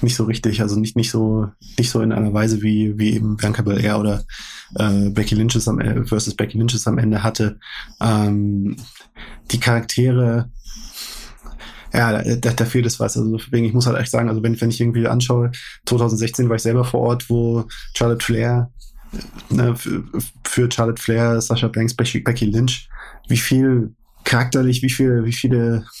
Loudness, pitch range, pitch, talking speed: -19 LUFS, 110-120 Hz, 115 Hz, 165 wpm